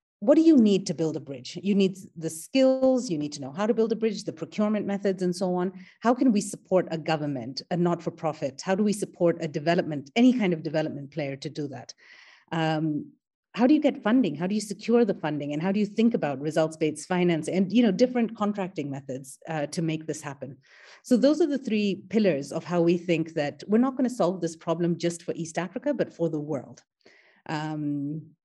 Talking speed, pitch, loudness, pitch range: 225 wpm, 175 Hz, -26 LUFS, 155-210 Hz